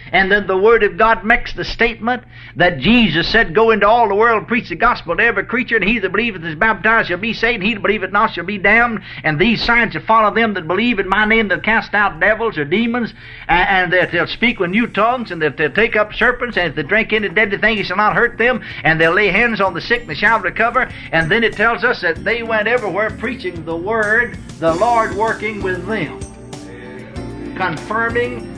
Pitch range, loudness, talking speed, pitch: 180-230 Hz, -15 LUFS, 235 wpm, 215 Hz